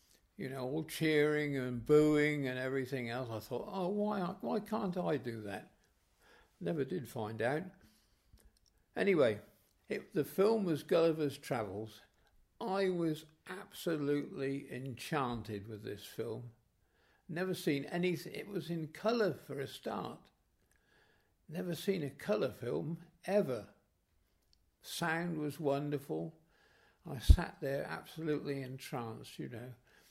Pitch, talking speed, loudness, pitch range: 145 Hz, 125 wpm, -37 LUFS, 120-175 Hz